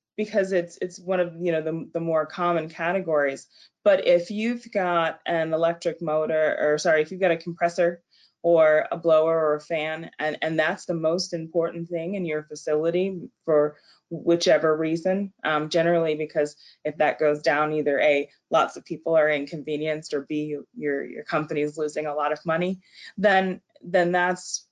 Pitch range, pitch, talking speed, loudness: 155-175 Hz, 165 Hz, 175 wpm, -24 LUFS